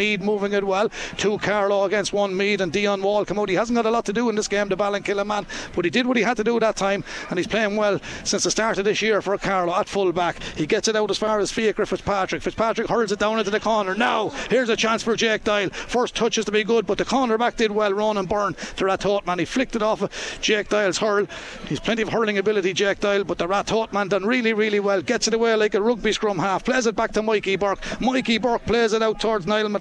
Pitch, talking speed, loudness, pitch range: 210 Hz, 275 wpm, -22 LUFS, 200-220 Hz